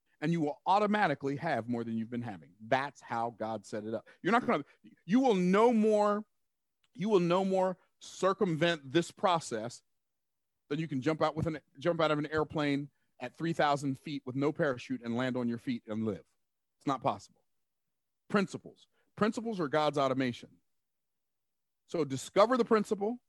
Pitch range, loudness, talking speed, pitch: 130-185 Hz, -32 LUFS, 180 wpm, 150 Hz